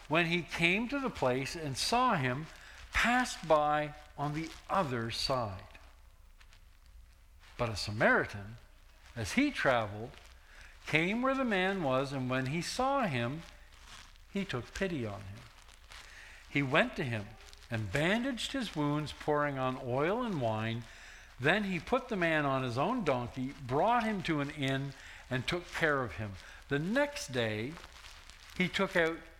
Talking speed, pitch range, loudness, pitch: 150 wpm, 110-175 Hz, -33 LUFS, 140 Hz